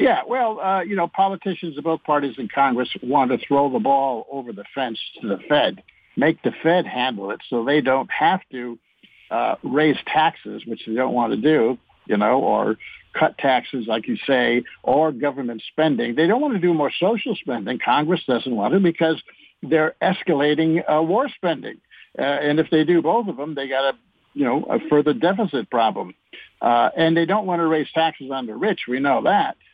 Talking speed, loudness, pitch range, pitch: 205 wpm, -21 LUFS, 135-170 Hz, 155 Hz